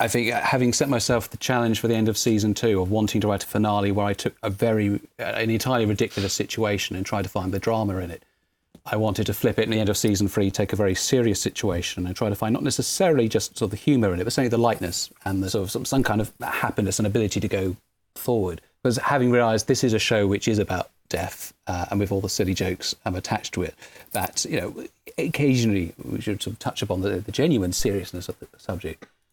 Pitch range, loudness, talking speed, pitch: 100-115 Hz, -24 LUFS, 250 wpm, 105 Hz